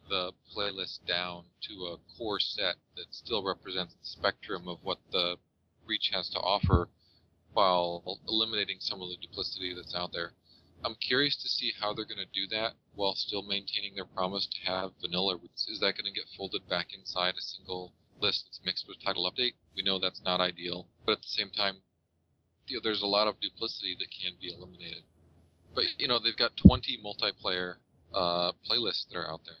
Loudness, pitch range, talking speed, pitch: -31 LUFS, 90-100 Hz, 195 wpm, 90 Hz